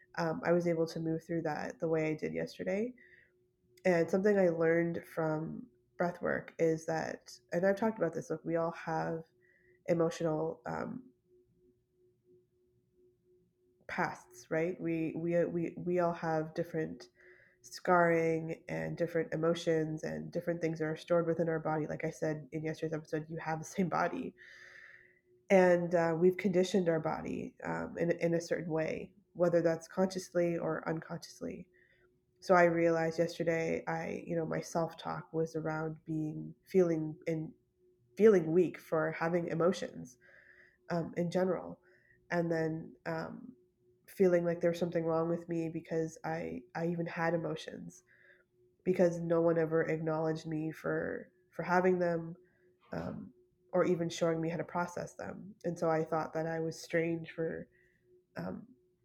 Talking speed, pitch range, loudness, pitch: 155 wpm, 160-175 Hz, -34 LUFS, 165 Hz